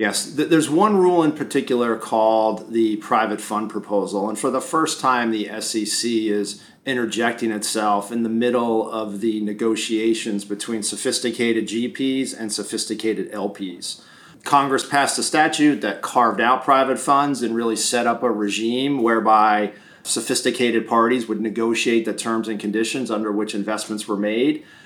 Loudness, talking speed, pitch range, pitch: -20 LUFS, 150 wpm, 110-125 Hz, 115 Hz